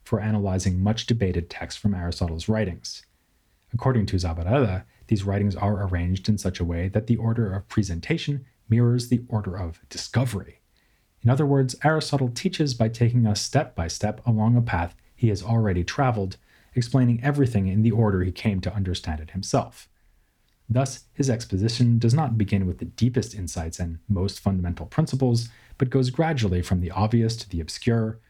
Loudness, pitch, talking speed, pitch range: -25 LUFS, 110 Hz, 170 wpm, 95-120 Hz